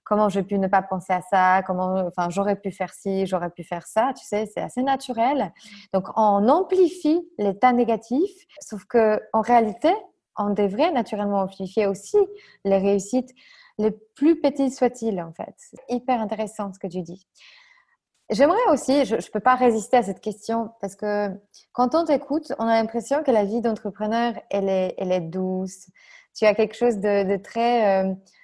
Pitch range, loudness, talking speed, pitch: 195-255 Hz, -23 LUFS, 185 wpm, 215 Hz